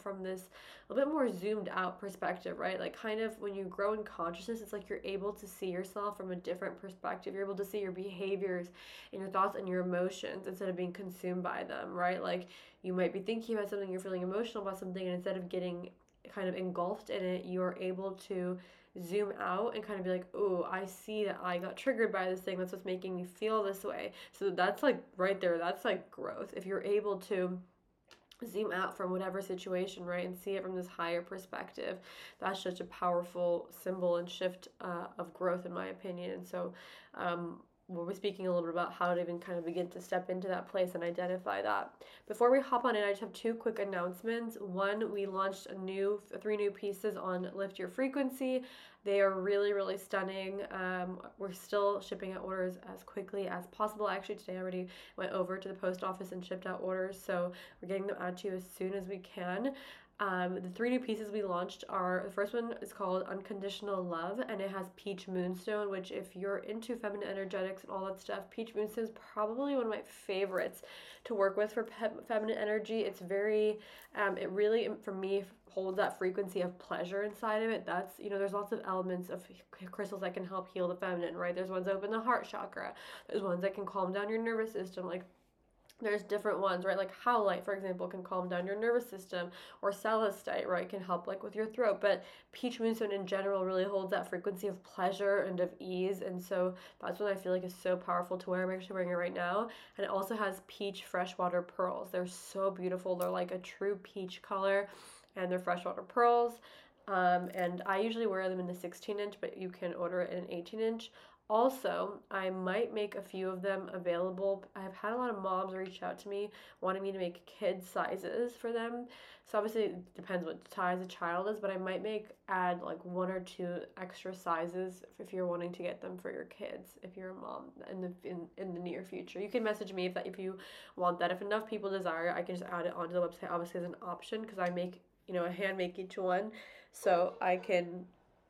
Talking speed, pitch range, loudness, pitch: 225 wpm, 180-205 Hz, -37 LUFS, 190 Hz